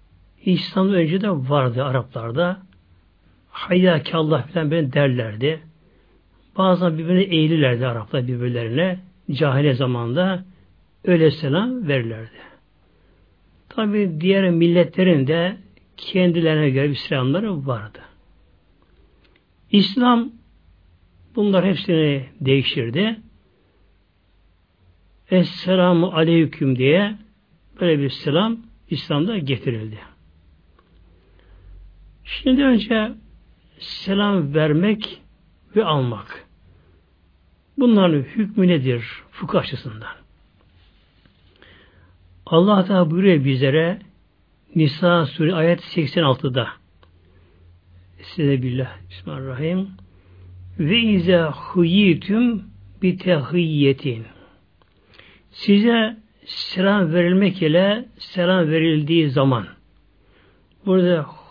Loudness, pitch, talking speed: -19 LUFS, 145 Hz, 75 wpm